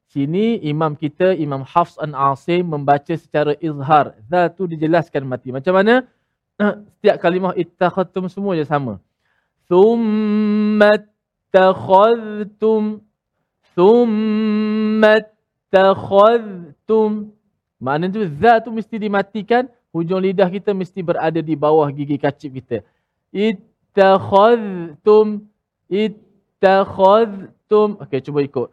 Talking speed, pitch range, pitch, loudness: 100 wpm, 155-215 Hz, 190 Hz, -16 LUFS